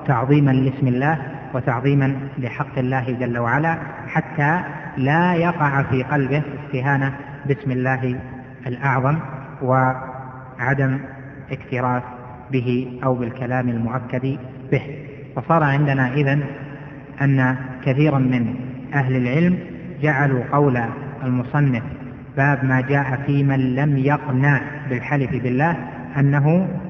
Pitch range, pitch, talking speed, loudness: 130-145 Hz, 135 Hz, 100 wpm, -20 LUFS